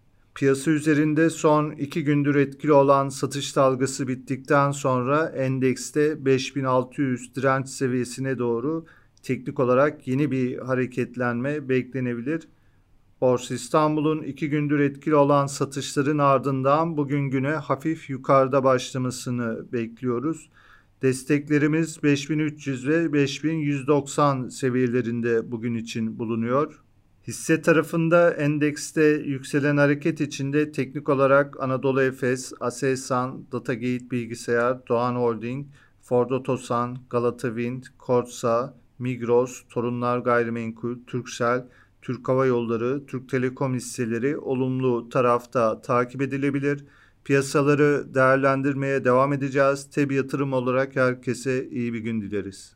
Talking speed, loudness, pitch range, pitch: 100 wpm, -24 LUFS, 125-145 Hz, 135 Hz